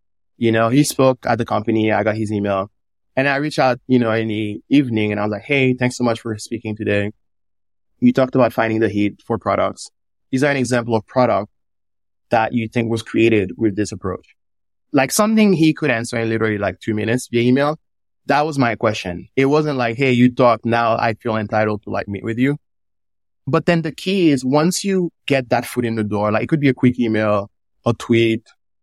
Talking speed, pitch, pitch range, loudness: 220 wpm, 115 Hz, 105-130 Hz, -18 LUFS